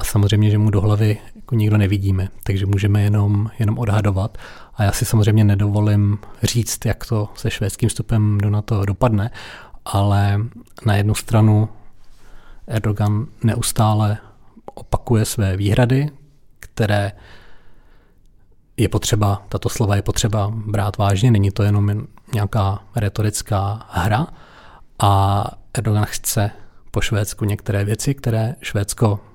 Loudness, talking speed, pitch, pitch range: -19 LUFS, 125 wpm, 105 Hz, 100-115 Hz